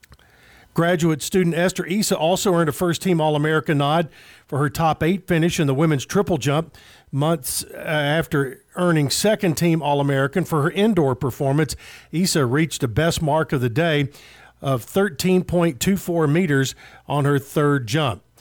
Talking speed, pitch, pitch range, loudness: 155 wpm, 155 Hz, 145-175 Hz, -20 LUFS